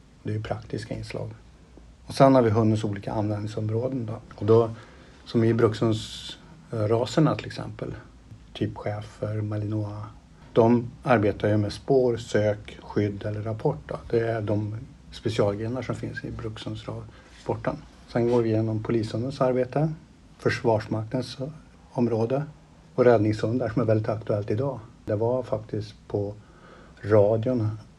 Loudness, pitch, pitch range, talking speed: -26 LUFS, 115 Hz, 105-125 Hz, 130 wpm